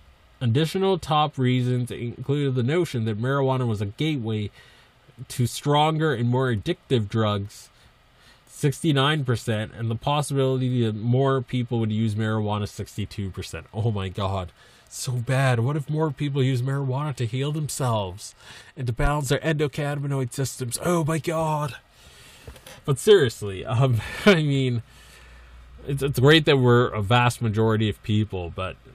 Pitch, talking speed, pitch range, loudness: 125 Hz, 140 wpm, 110-140 Hz, -24 LUFS